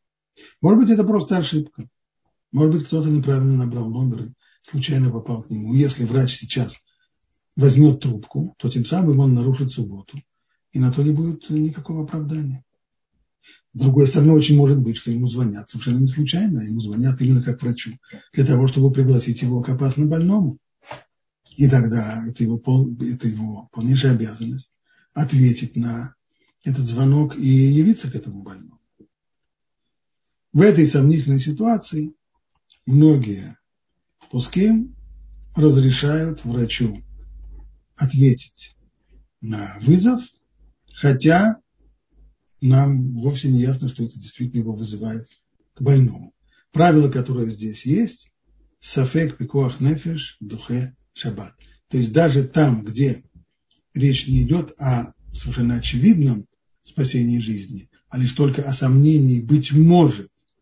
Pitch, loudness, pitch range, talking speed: 135 Hz, -19 LUFS, 120-150 Hz, 130 wpm